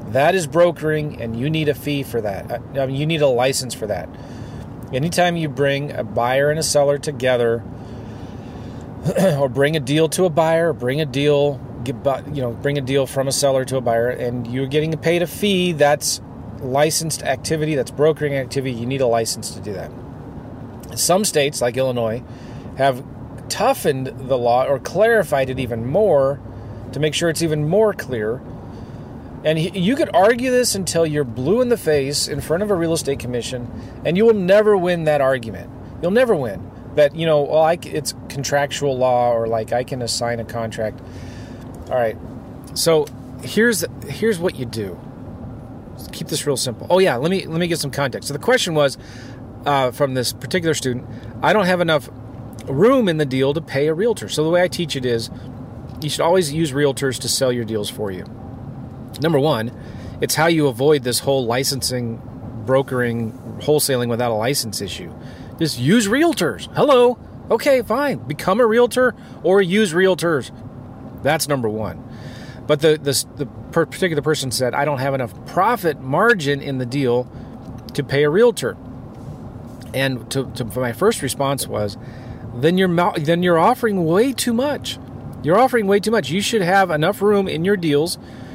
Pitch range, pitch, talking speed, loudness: 125-160 Hz, 140 Hz, 185 wpm, -19 LUFS